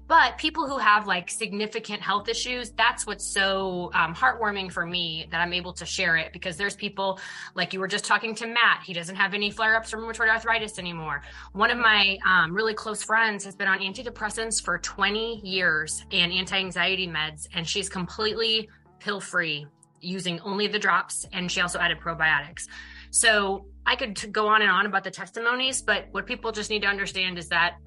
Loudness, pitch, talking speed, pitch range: -25 LUFS, 200 Hz, 200 wpm, 180-220 Hz